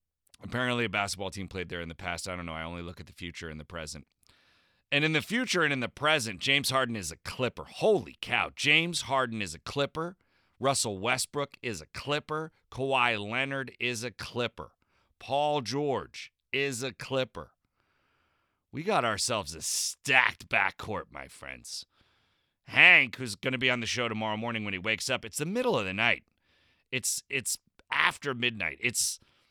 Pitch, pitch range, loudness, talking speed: 125 Hz, 100-140 Hz, -28 LUFS, 180 wpm